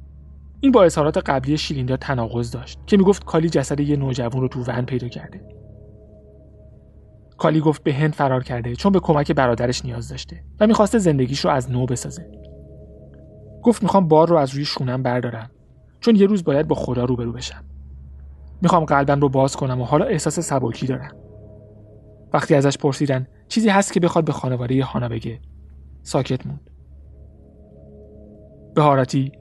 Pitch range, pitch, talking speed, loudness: 105-150 Hz, 130 Hz, 155 wpm, -19 LUFS